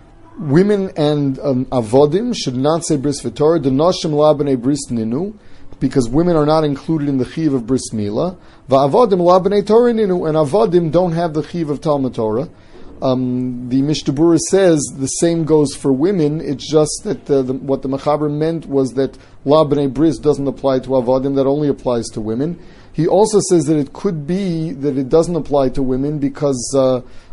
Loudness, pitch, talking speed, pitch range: -16 LUFS, 145 Hz, 180 wpm, 135-165 Hz